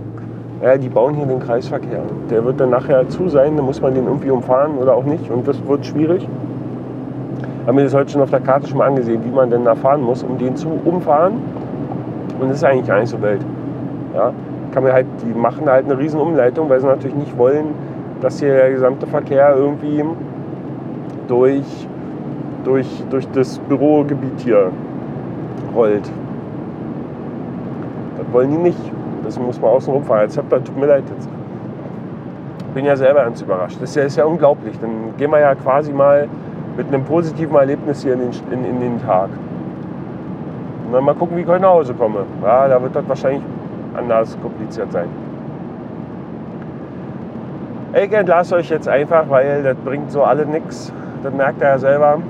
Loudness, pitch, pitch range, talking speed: -16 LUFS, 140 Hz, 130-150 Hz, 175 wpm